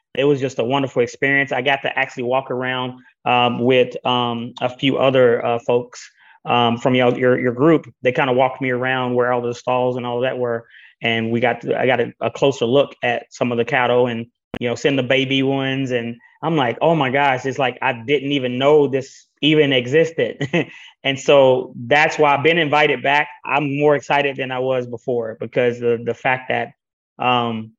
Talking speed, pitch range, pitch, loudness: 210 wpm, 120-140 Hz, 130 Hz, -18 LUFS